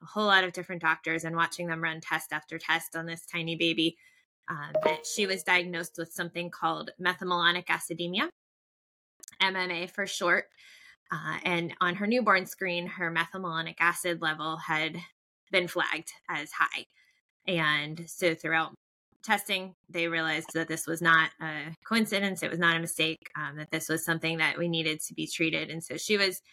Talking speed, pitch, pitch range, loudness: 175 wpm, 170 Hz, 160-185 Hz, -29 LUFS